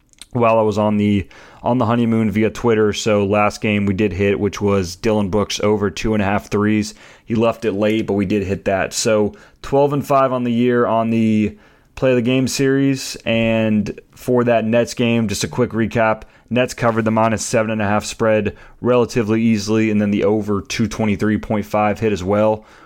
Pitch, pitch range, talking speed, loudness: 110 Hz, 105-120 Hz, 200 wpm, -18 LUFS